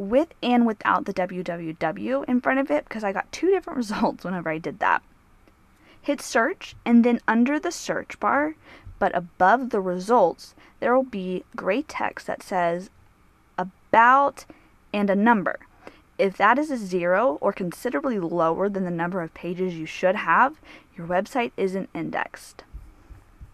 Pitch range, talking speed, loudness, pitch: 180-250 Hz, 160 wpm, -24 LUFS, 200 Hz